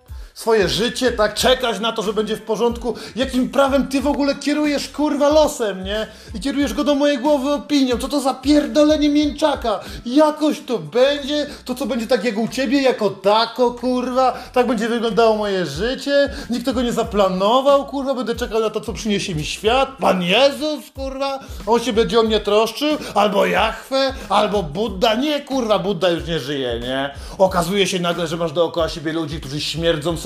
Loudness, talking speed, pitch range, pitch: -19 LUFS, 185 wpm, 205-275 Hz, 235 Hz